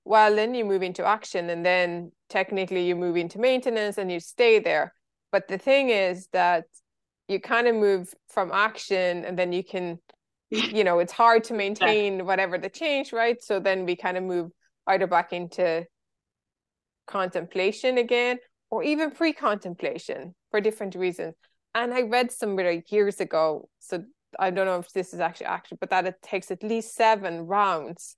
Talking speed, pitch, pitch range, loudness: 175 wpm, 190 Hz, 180-225 Hz, -25 LUFS